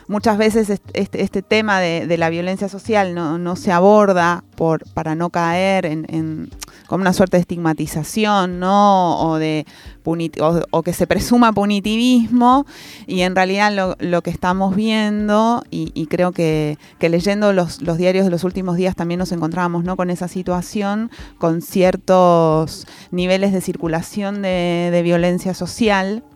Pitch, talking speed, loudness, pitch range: 180 Hz, 160 wpm, -17 LUFS, 170-200 Hz